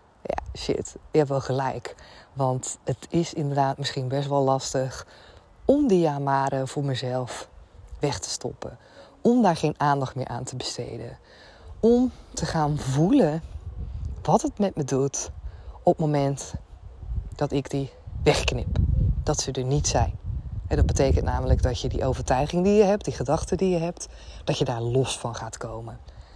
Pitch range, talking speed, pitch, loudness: 125-155 Hz, 170 wpm, 140 Hz, -25 LUFS